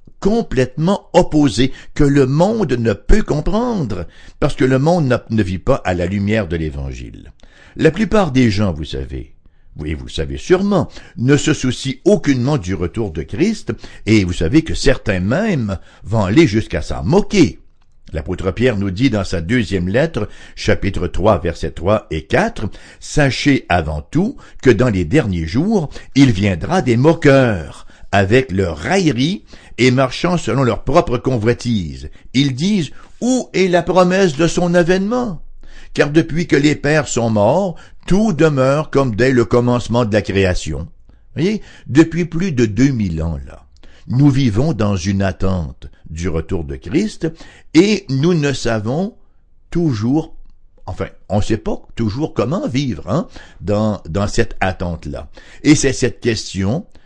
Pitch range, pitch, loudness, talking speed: 95-155 Hz, 125 Hz, -16 LUFS, 160 wpm